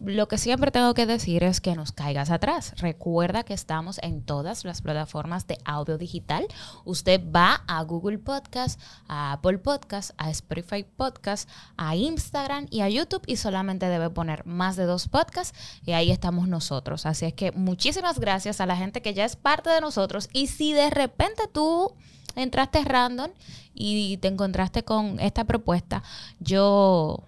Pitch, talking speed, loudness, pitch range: 195 Hz, 170 wpm, -26 LUFS, 170-250 Hz